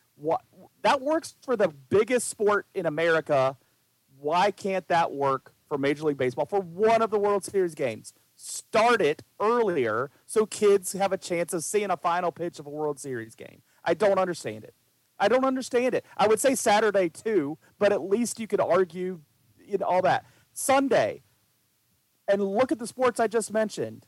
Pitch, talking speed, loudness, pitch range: 195 Hz, 185 wpm, -26 LUFS, 155-220 Hz